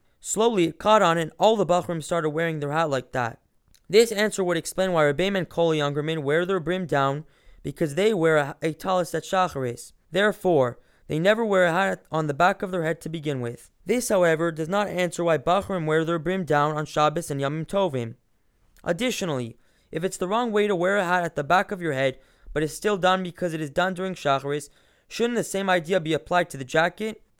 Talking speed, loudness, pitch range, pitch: 220 wpm, -24 LUFS, 150-190 Hz, 170 Hz